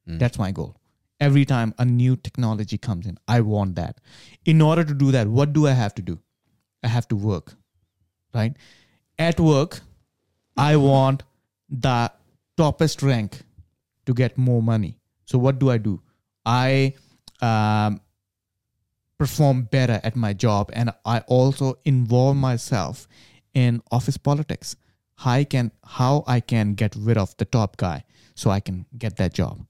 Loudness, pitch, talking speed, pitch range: -22 LUFS, 120 Hz, 160 wpm, 105-135 Hz